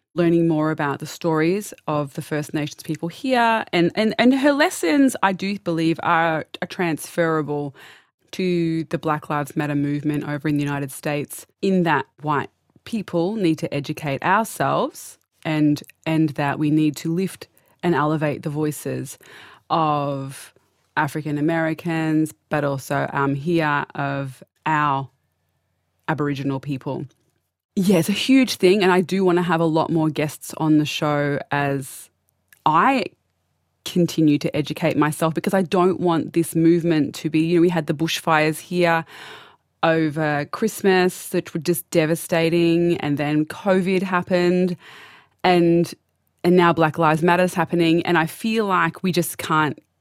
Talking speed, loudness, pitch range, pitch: 150 wpm, -21 LUFS, 150-175 Hz, 160 Hz